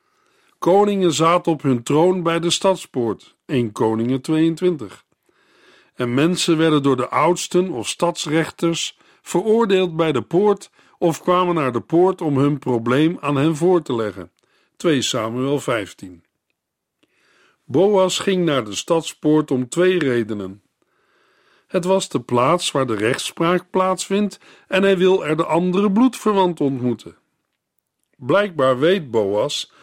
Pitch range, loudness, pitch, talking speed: 135-185 Hz, -19 LUFS, 165 Hz, 135 wpm